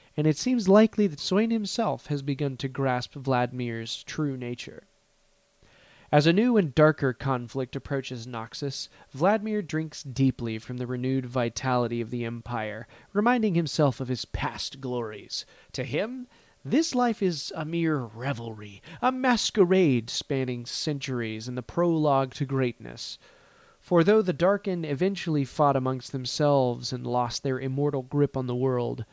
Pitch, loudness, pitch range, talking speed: 135 Hz, -27 LUFS, 125-170 Hz, 145 wpm